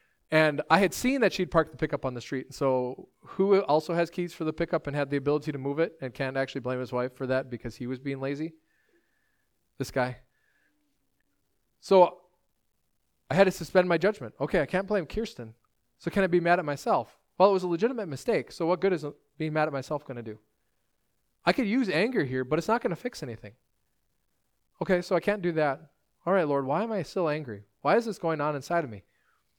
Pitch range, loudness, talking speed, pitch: 135-185 Hz, -28 LUFS, 230 wpm, 155 Hz